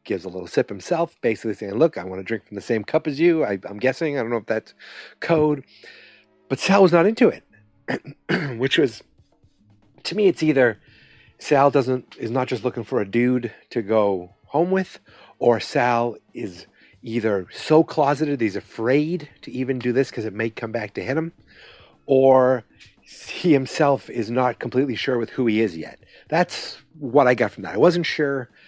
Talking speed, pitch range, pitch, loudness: 195 wpm, 115-150 Hz, 130 Hz, -21 LUFS